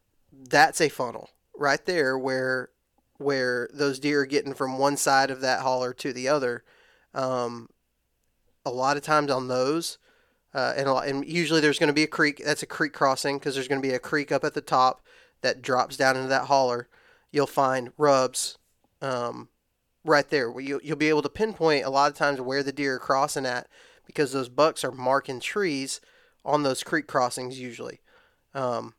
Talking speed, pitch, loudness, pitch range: 195 wpm, 135 Hz, -25 LUFS, 130-145 Hz